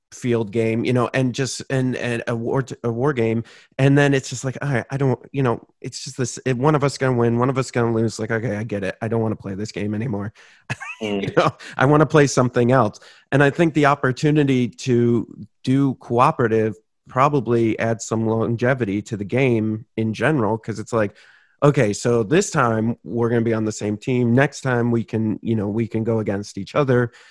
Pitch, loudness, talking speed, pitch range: 120 Hz, -20 LUFS, 225 wpm, 110-135 Hz